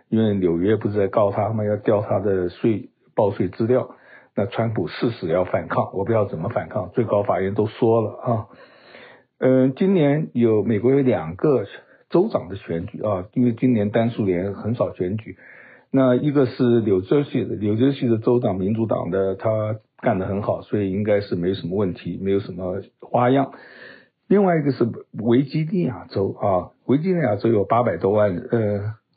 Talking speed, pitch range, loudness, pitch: 275 characters per minute, 100-125 Hz, -21 LUFS, 115 Hz